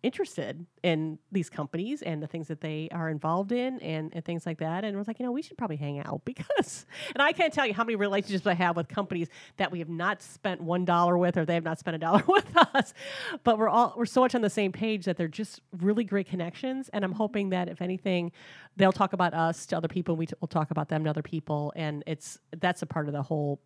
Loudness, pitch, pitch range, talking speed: -29 LUFS, 175 Hz, 160-205 Hz, 265 wpm